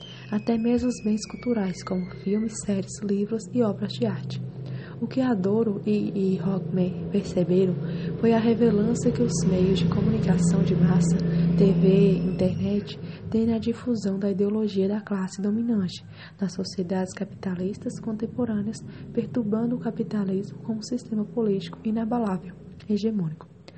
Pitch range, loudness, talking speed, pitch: 185-225 Hz, -25 LUFS, 135 wpm, 200 Hz